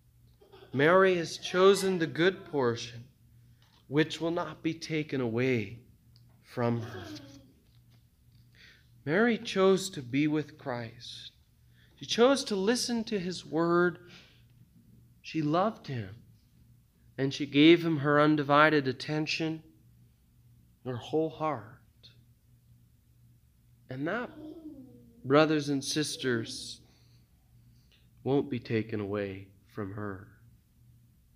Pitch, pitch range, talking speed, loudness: 130 Hz, 115-160 Hz, 100 wpm, -29 LUFS